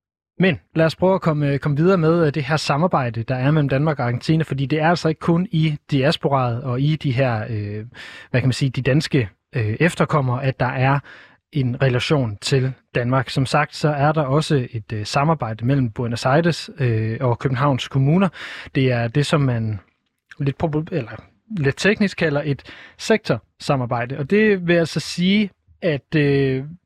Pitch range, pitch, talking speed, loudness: 125-160 Hz, 140 Hz, 185 wpm, -20 LUFS